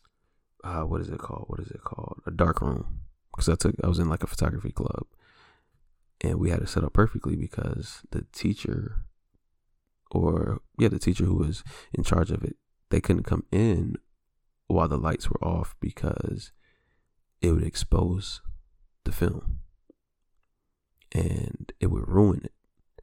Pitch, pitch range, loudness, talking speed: 85 Hz, 80-100 Hz, -28 LUFS, 160 wpm